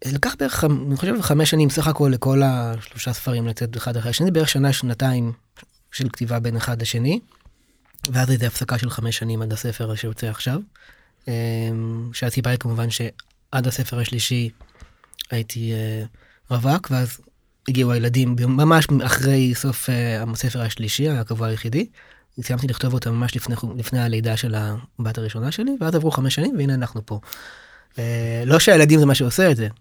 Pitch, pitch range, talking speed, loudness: 125 Hz, 115-135 Hz, 155 wpm, -21 LUFS